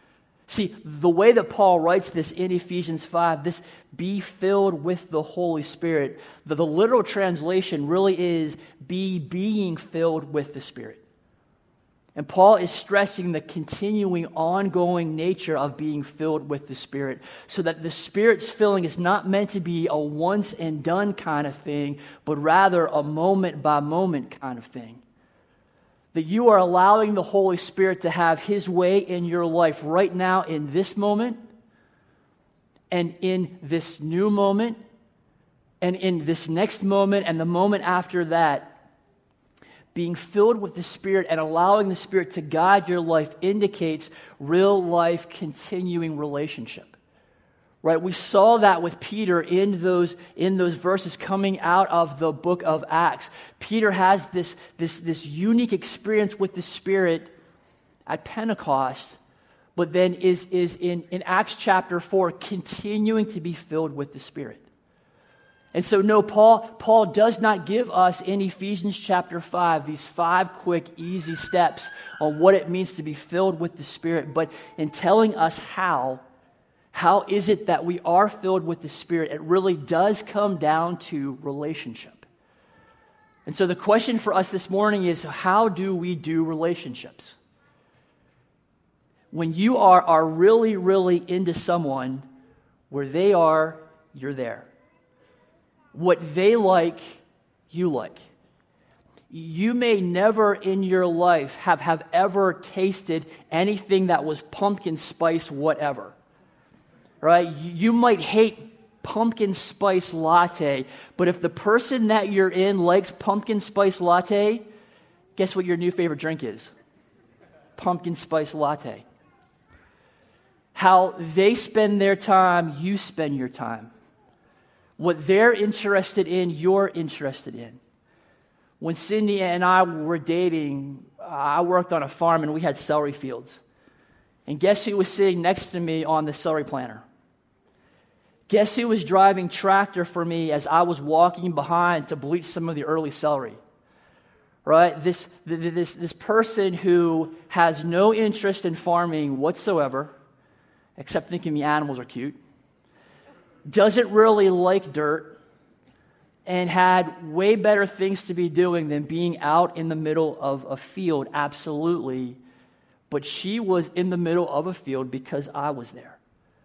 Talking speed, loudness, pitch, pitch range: 145 wpm, -22 LUFS, 175 Hz, 160-195 Hz